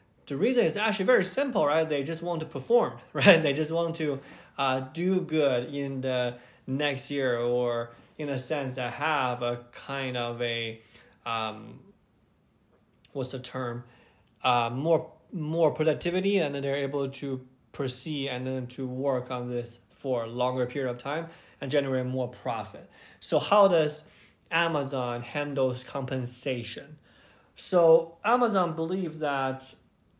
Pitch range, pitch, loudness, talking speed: 125-160 Hz, 135 Hz, -28 LUFS, 145 wpm